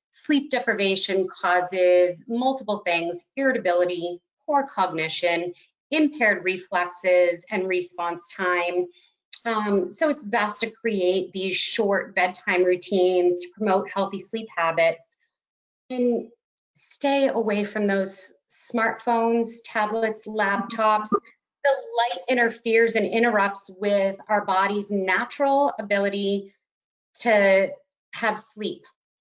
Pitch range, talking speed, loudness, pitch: 180-230 Hz, 100 wpm, -23 LUFS, 200 Hz